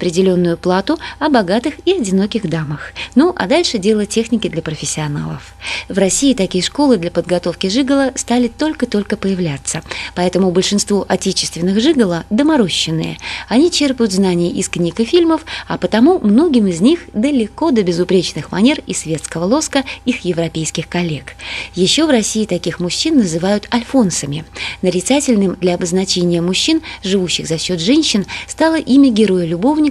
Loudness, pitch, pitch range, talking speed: -15 LUFS, 195 Hz, 175-260 Hz, 140 wpm